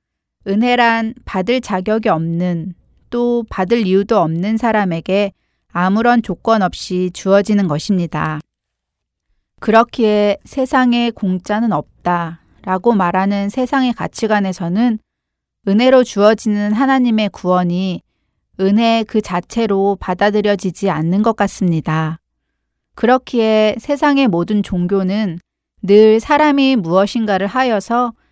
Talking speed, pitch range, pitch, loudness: 255 characters per minute, 185-230 Hz, 205 Hz, -15 LUFS